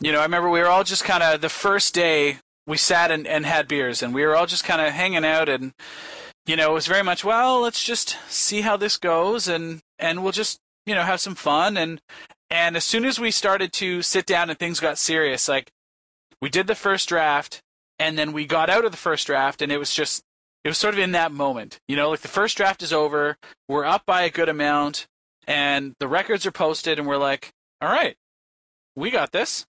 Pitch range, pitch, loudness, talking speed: 150-190 Hz, 165 Hz, -21 LUFS, 240 wpm